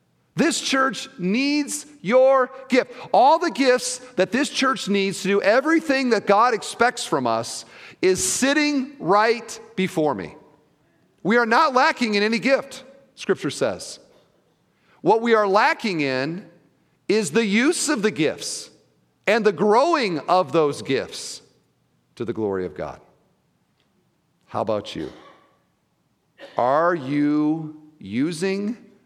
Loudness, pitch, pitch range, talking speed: -21 LUFS, 215 Hz, 175-265 Hz, 130 wpm